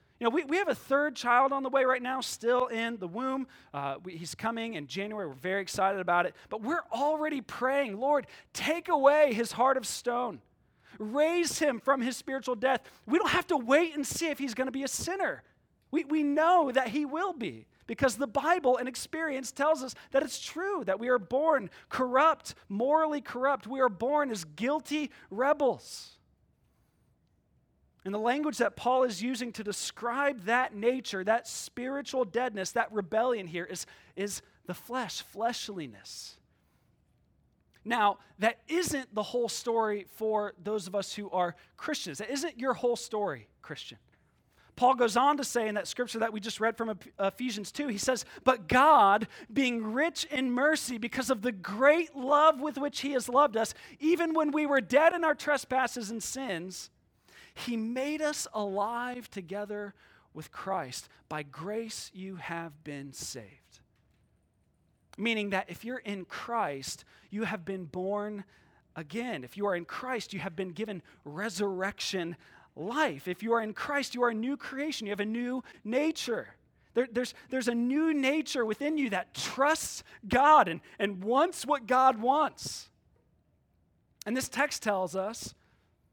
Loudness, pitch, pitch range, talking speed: -30 LUFS, 245 Hz, 205-280 Hz, 170 wpm